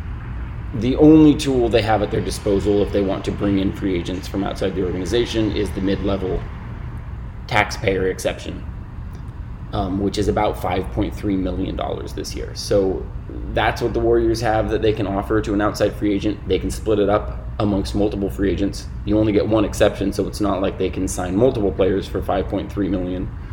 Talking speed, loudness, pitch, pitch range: 200 wpm, -20 LUFS, 100 Hz, 95-110 Hz